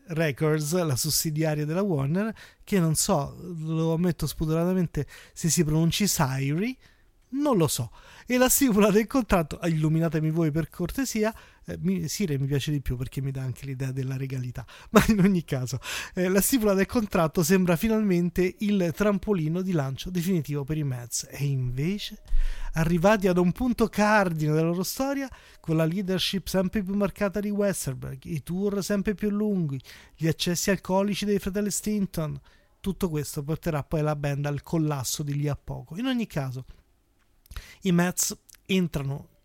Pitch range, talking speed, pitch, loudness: 150-200 Hz, 160 wpm, 170 Hz, -26 LUFS